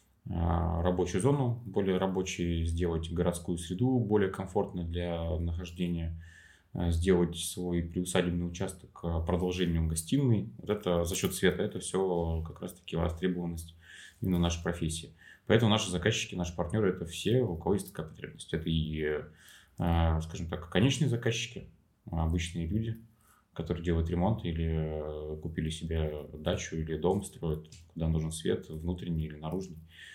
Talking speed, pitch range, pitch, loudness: 135 wpm, 85-95 Hz, 85 Hz, -32 LUFS